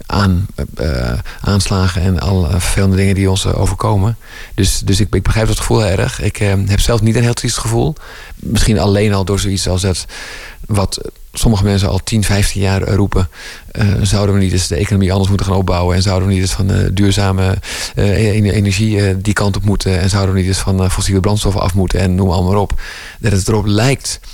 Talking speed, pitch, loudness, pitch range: 215 wpm, 100 Hz, -14 LUFS, 95-105 Hz